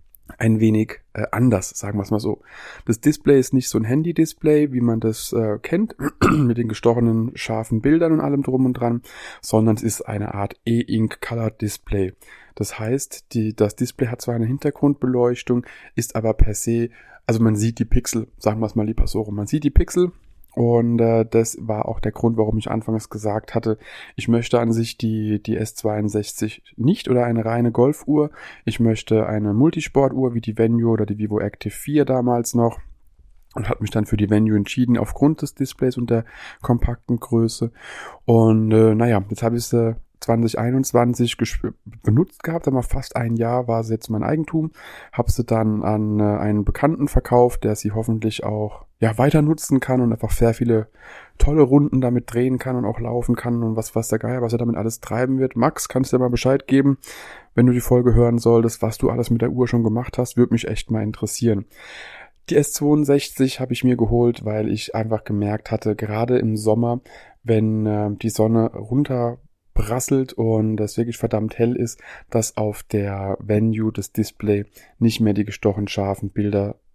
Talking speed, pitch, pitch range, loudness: 195 wpm, 115 Hz, 110-125 Hz, -20 LUFS